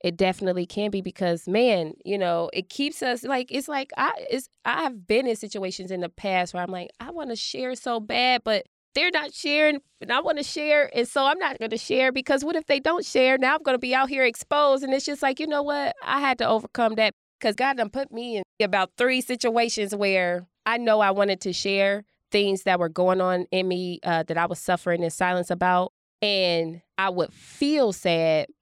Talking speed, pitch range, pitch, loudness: 235 wpm, 185-265 Hz, 220 Hz, -24 LUFS